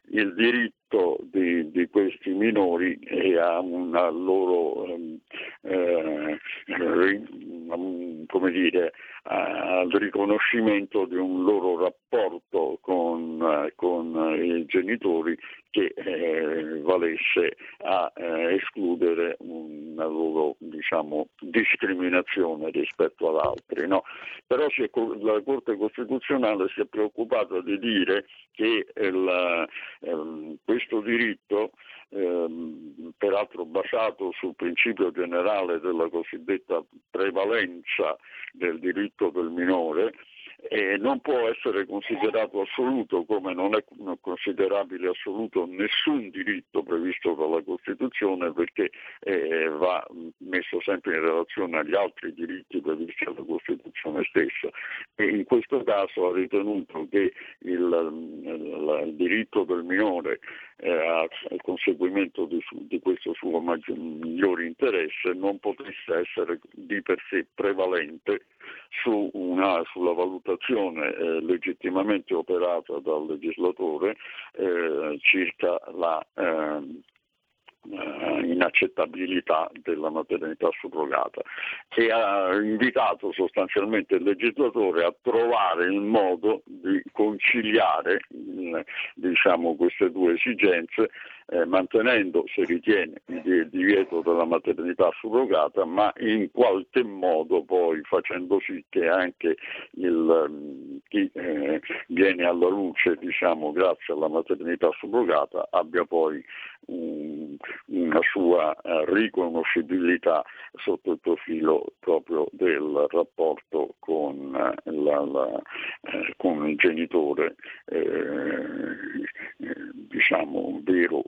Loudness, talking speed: -26 LUFS, 105 wpm